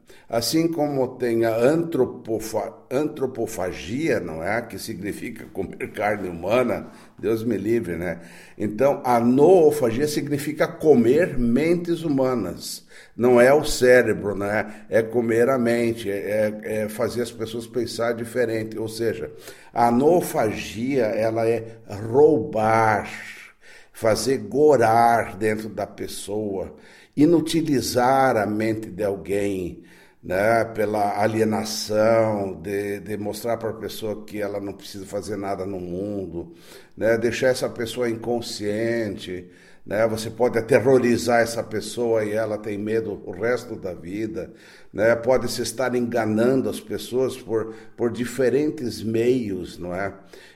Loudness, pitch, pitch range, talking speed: -22 LUFS, 115 Hz, 105-120 Hz, 125 wpm